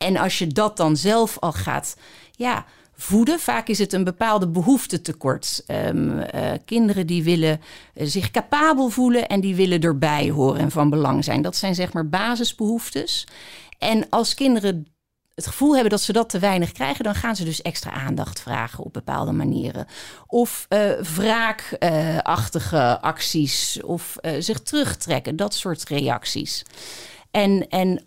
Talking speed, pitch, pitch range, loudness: 160 wpm, 190 Hz, 160-225 Hz, -21 LUFS